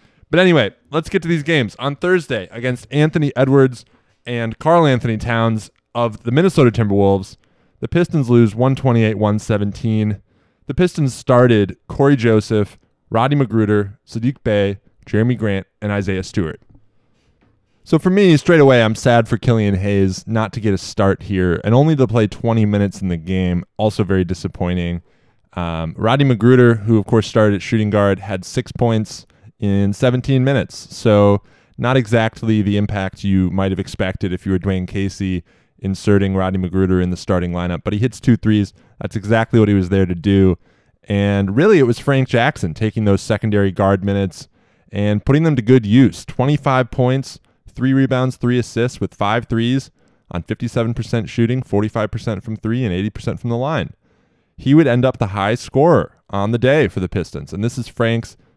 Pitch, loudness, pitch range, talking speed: 110 Hz, -17 LUFS, 100-125 Hz, 175 wpm